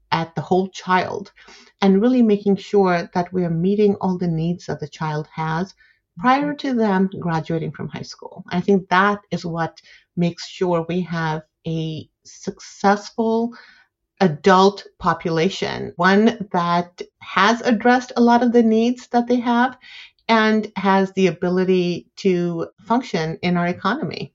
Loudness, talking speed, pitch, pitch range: -20 LUFS, 150 wpm, 190 Hz, 175-220 Hz